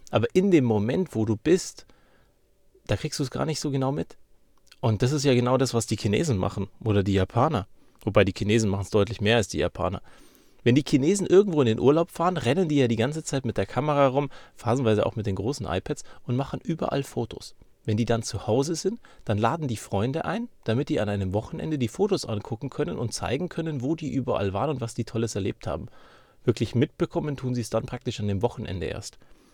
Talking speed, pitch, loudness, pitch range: 225 wpm, 120 Hz, -26 LUFS, 110-145 Hz